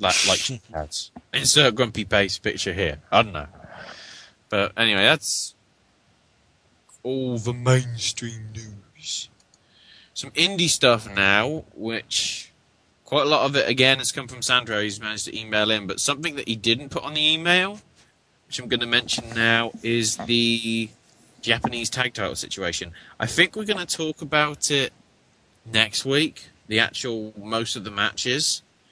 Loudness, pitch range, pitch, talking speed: -22 LUFS, 110-130 Hz, 115 Hz, 155 wpm